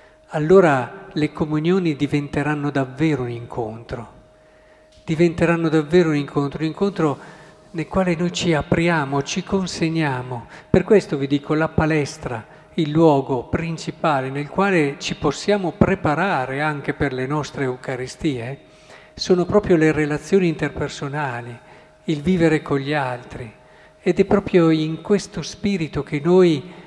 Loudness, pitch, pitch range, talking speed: -20 LUFS, 155 Hz, 145-175 Hz, 125 wpm